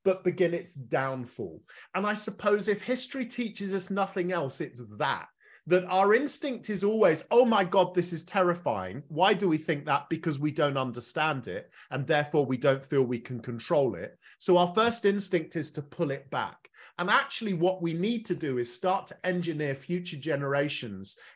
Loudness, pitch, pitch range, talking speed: -28 LUFS, 175 Hz, 145-195 Hz, 190 wpm